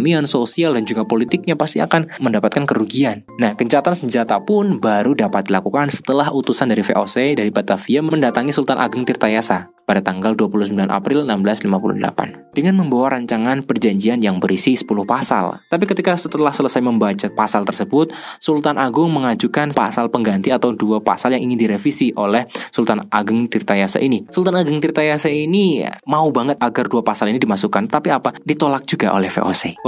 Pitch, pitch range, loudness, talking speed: 135 Hz, 110-155 Hz, -17 LUFS, 155 wpm